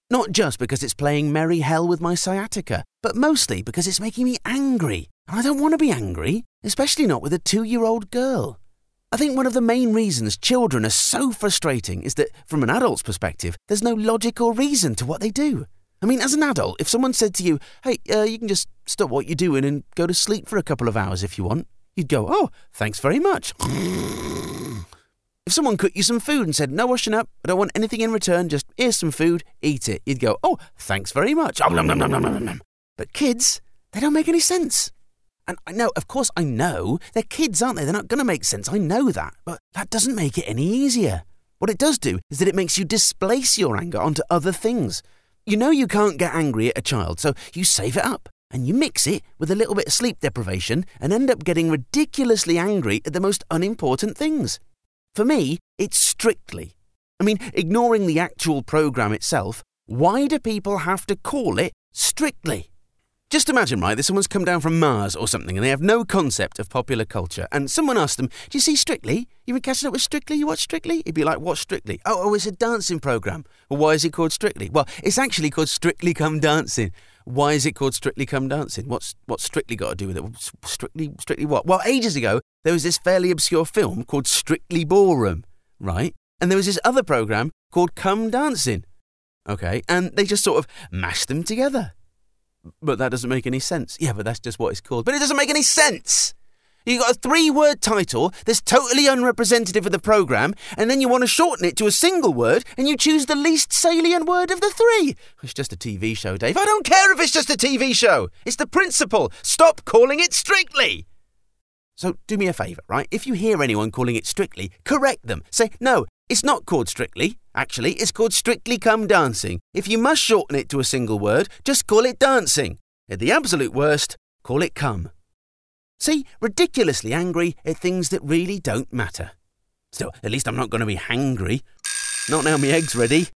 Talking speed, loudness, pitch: 220 wpm, -20 LUFS, 180 Hz